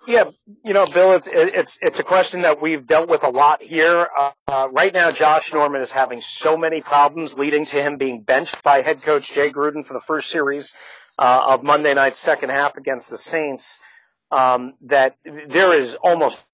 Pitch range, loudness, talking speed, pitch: 140-165 Hz, -18 LUFS, 195 wpm, 150 Hz